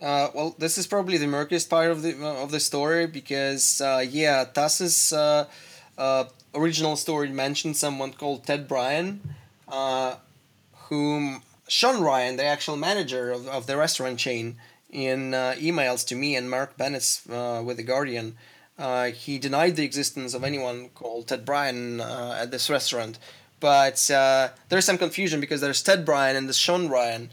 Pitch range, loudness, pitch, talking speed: 130-150 Hz, -24 LUFS, 135 Hz, 170 wpm